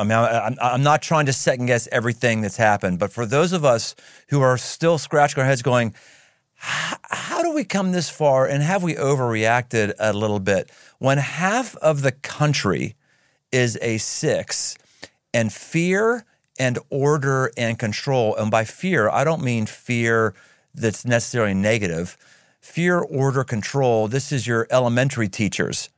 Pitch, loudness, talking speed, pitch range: 130 Hz, -21 LUFS, 160 wpm, 115-145 Hz